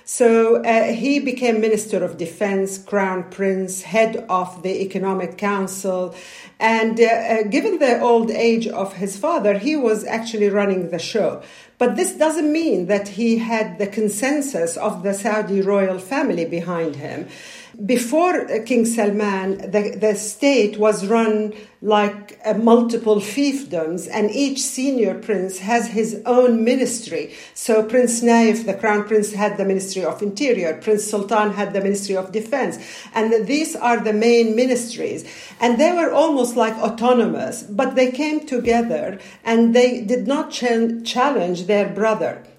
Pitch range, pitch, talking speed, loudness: 200-240 Hz, 220 Hz, 150 wpm, -19 LUFS